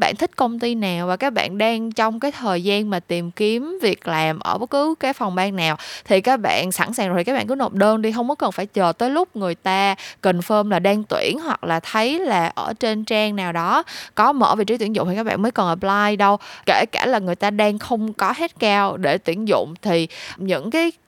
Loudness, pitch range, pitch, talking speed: -20 LUFS, 185-240 Hz, 210 Hz, 255 wpm